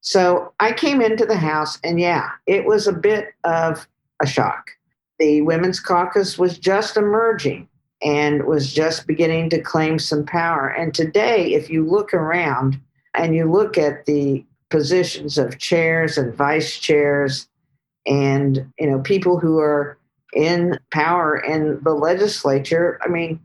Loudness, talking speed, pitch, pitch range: -19 LUFS, 150 wpm, 160 Hz, 145-180 Hz